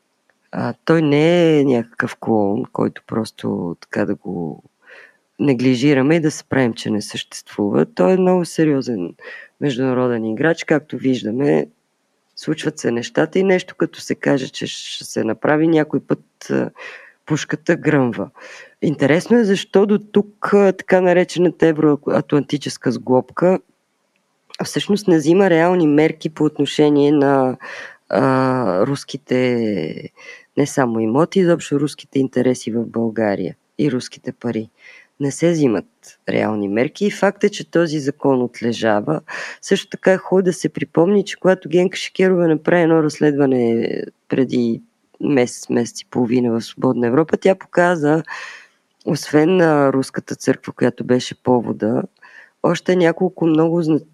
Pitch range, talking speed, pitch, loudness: 125-170 Hz, 135 wpm, 150 Hz, -18 LUFS